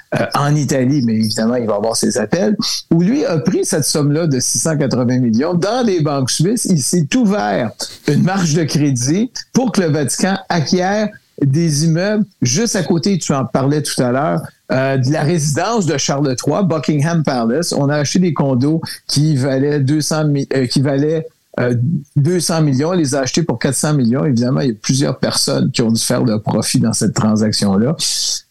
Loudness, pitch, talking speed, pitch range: -15 LUFS, 150 Hz, 195 wpm, 135-175 Hz